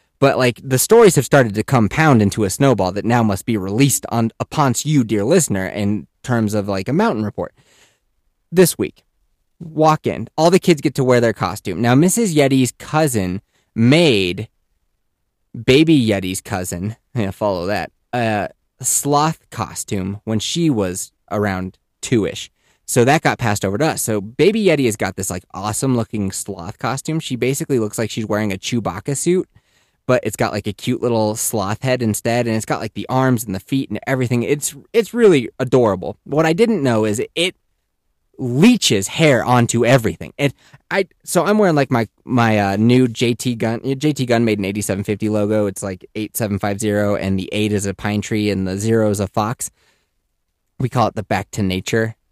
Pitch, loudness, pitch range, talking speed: 115 Hz, -17 LUFS, 105-135 Hz, 185 wpm